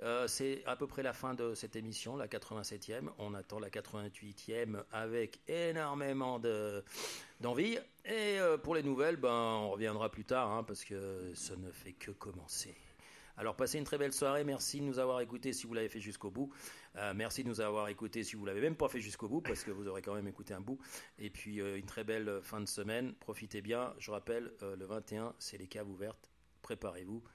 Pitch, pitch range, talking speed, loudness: 110 Hz, 105-130 Hz, 215 wpm, -40 LUFS